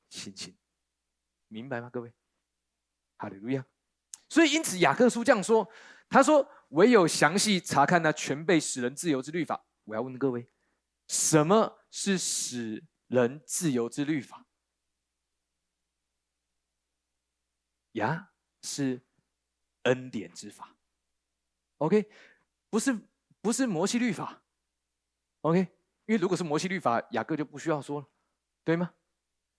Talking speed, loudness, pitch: 195 characters per minute, -28 LUFS, 130 Hz